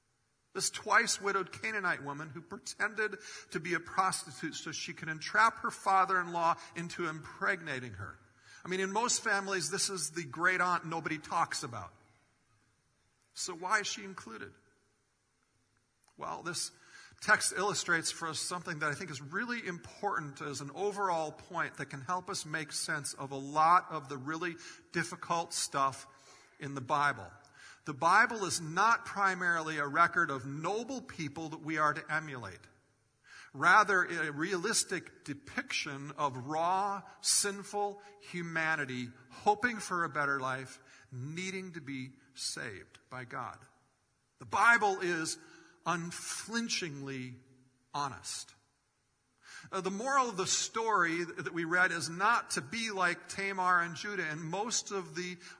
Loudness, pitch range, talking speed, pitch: -33 LUFS, 145-195 Hz, 145 wpm, 170 Hz